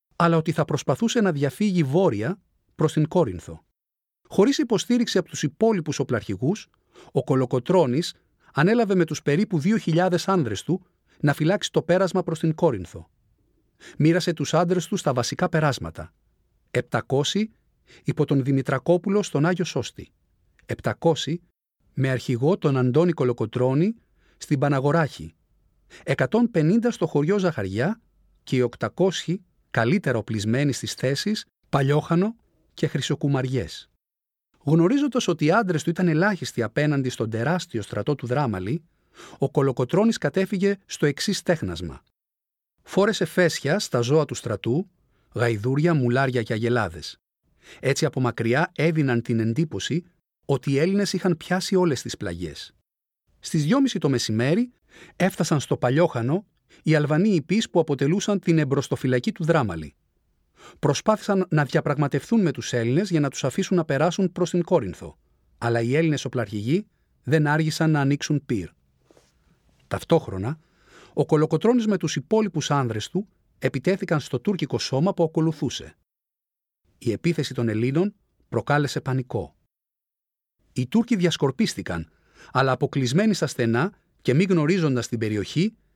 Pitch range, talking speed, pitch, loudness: 125-180 Hz, 125 wpm, 150 Hz, -23 LUFS